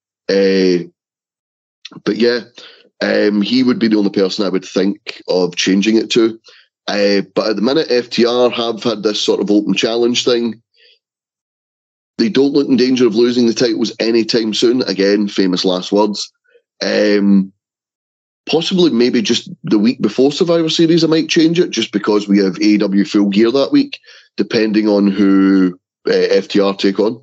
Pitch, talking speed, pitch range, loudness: 110 Hz, 165 wpm, 100-125 Hz, -14 LUFS